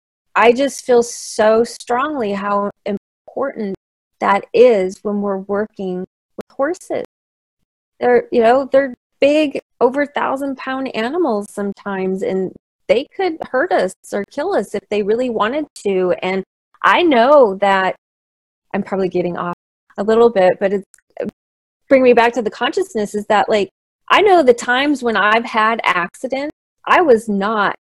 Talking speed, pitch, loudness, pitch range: 150 wpm, 220 Hz, -16 LUFS, 195-260 Hz